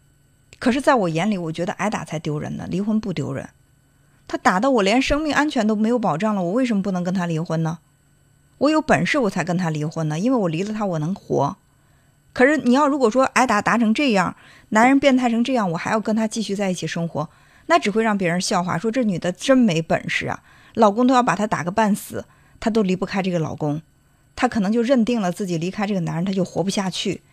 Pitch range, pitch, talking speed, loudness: 165-235 Hz, 200 Hz, 340 characters per minute, -20 LUFS